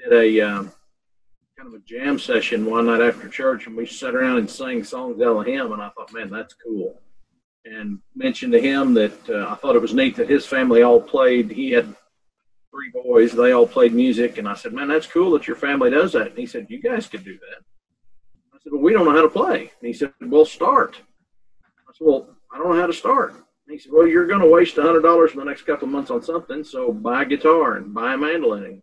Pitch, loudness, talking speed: 175 Hz, -18 LUFS, 250 wpm